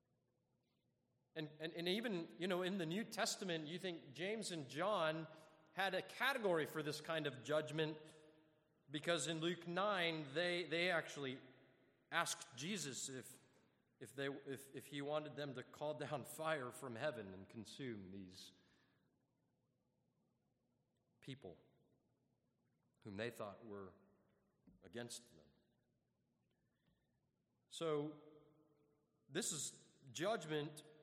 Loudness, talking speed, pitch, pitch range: -44 LUFS, 115 wpm, 155 Hz, 130-170 Hz